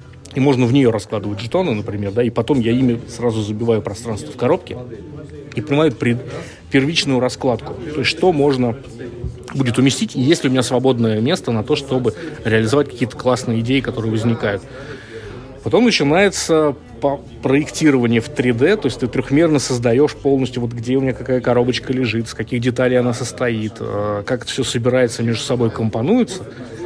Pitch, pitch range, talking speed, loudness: 125 Hz, 115-140 Hz, 160 wpm, -17 LUFS